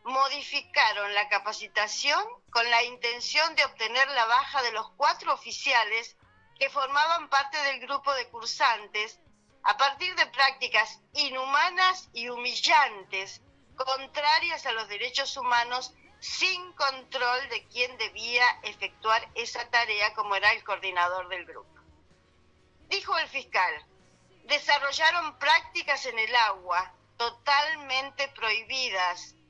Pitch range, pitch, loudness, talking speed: 215-285 Hz, 250 Hz, -26 LUFS, 115 wpm